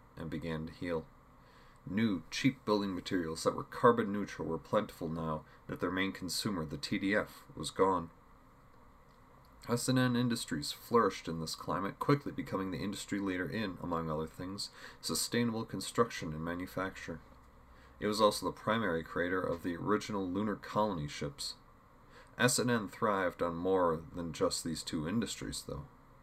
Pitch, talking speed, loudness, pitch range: 90 Hz, 155 wpm, -35 LUFS, 80-105 Hz